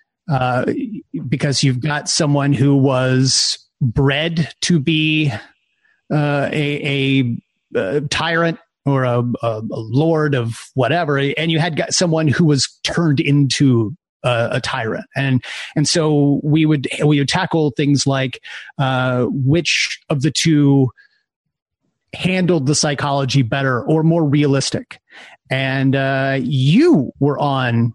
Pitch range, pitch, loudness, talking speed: 135-155 Hz, 140 Hz, -17 LUFS, 135 wpm